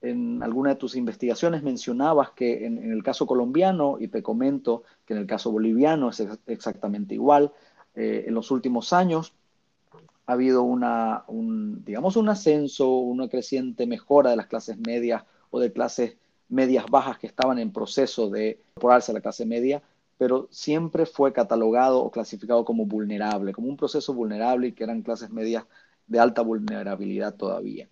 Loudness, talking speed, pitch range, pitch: -25 LUFS, 170 wpm, 115-140 Hz, 125 Hz